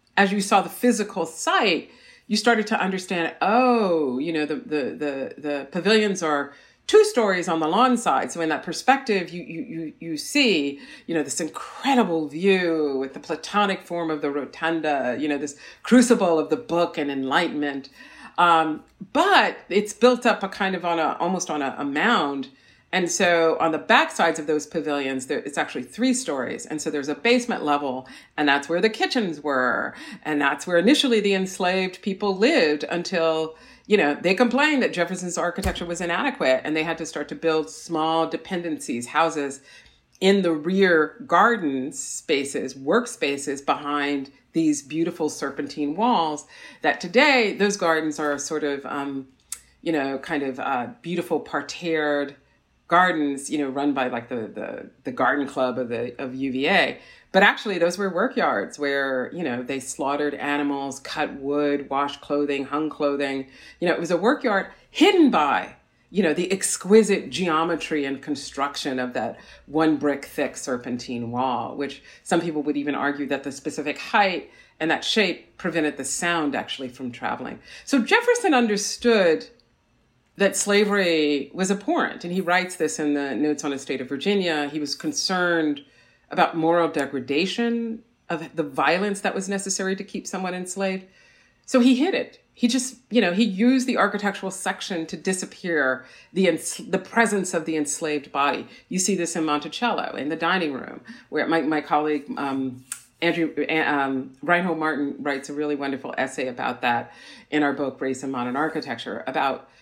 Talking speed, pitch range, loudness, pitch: 170 wpm, 145-195 Hz, -23 LUFS, 160 Hz